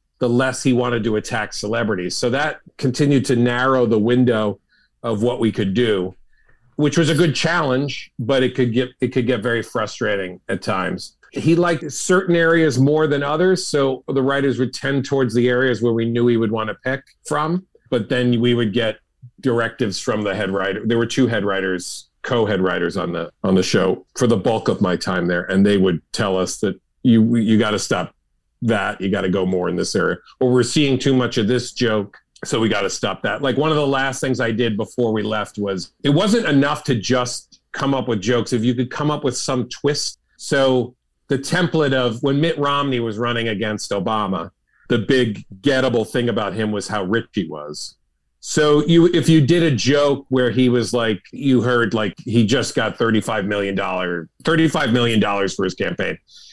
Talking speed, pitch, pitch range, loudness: 210 wpm, 125 Hz, 110-140 Hz, -19 LUFS